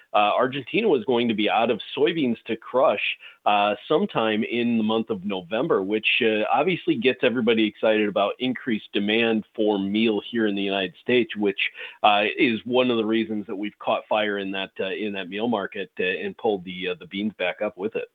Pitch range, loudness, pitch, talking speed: 100-115 Hz, -23 LUFS, 110 Hz, 210 wpm